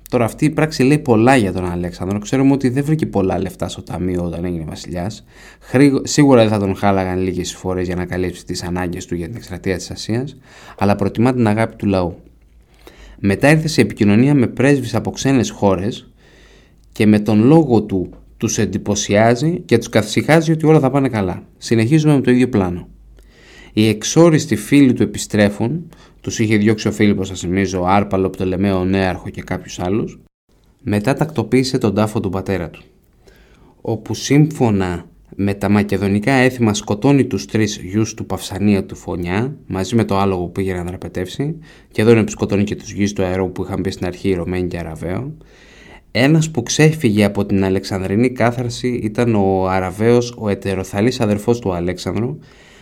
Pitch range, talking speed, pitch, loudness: 95-120 Hz, 185 wpm, 105 Hz, -17 LUFS